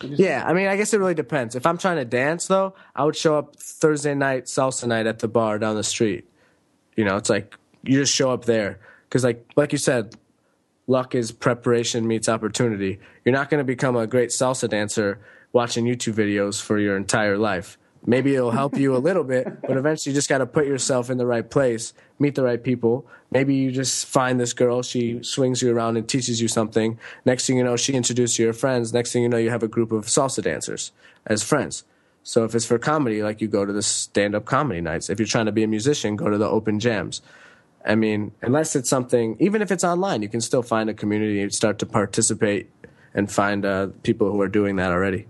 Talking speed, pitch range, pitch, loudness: 235 wpm, 110-135 Hz, 120 Hz, -22 LUFS